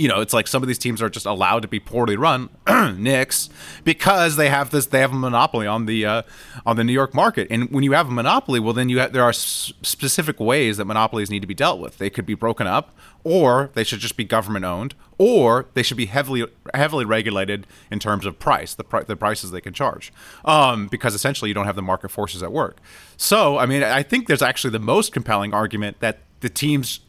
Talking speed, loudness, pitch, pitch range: 240 wpm, -20 LUFS, 115 Hz, 105-130 Hz